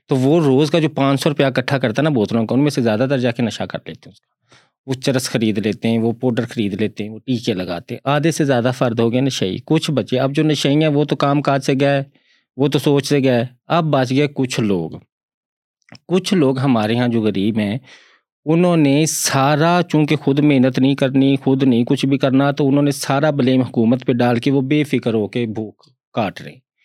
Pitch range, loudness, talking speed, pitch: 120-145 Hz, -17 LUFS, 240 wpm, 135 Hz